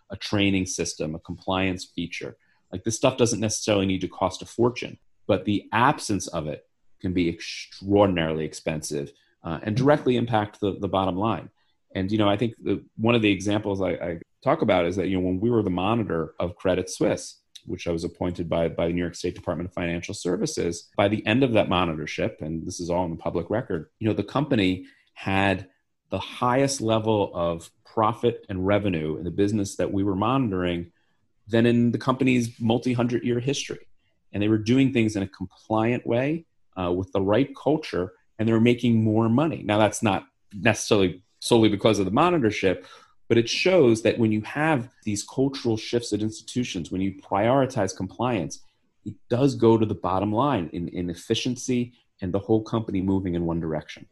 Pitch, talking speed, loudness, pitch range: 100 Hz, 195 wpm, -25 LUFS, 90-115 Hz